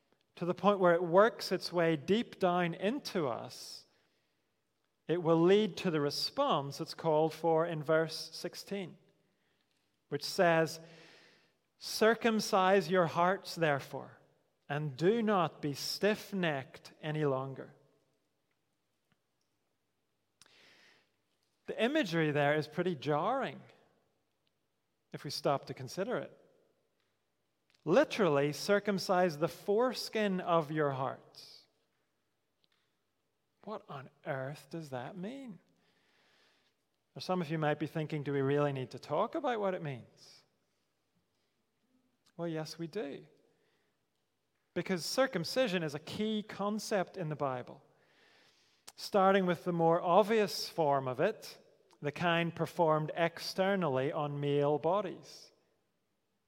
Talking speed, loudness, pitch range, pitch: 115 wpm, -33 LUFS, 150-200 Hz, 170 Hz